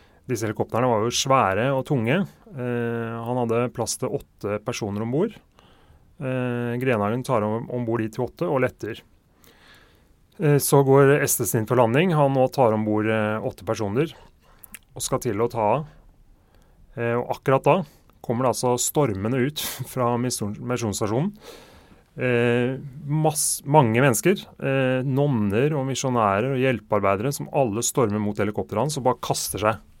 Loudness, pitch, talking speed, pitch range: -23 LUFS, 125 Hz, 150 wpm, 110-135 Hz